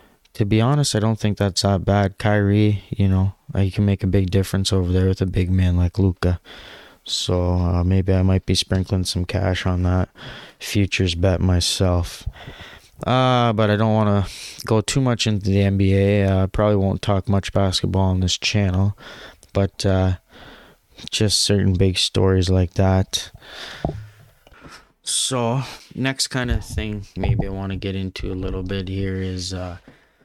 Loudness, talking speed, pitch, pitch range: -20 LUFS, 175 wpm, 95 Hz, 95-105 Hz